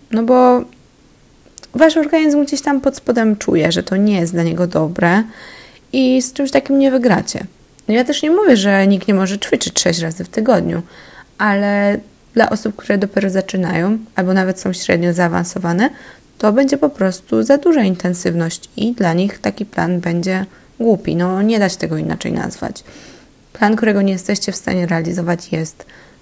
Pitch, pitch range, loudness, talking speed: 200 Hz, 180-245 Hz, -15 LUFS, 175 wpm